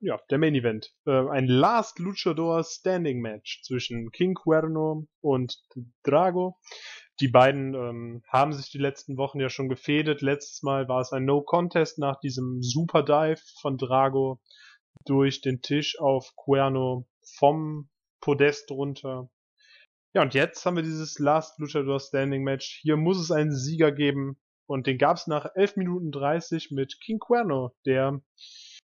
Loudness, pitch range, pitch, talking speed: -26 LUFS, 135-155 Hz, 140 Hz, 155 wpm